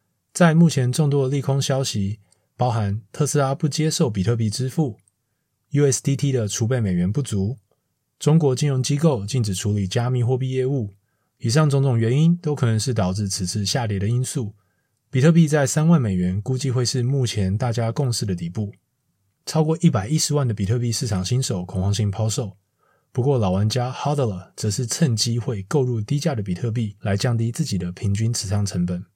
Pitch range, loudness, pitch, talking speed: 105-140 Hz, -21 LUFS, 120 Hz, 300 characters per minute